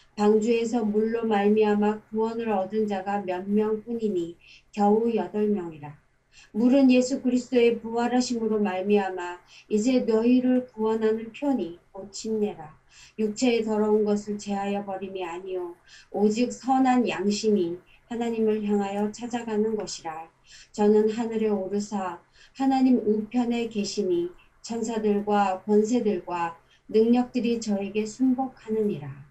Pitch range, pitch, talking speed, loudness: 195-230 Hz, 215 Hz, 285 characters per minute, -25 LUFS